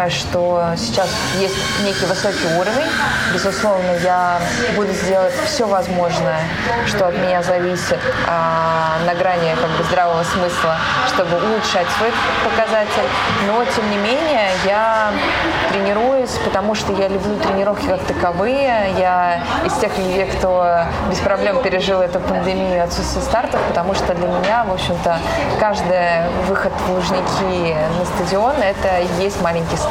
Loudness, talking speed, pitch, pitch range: -17 LUFS, 135 wpm, 185 Hz, 175-205 Hz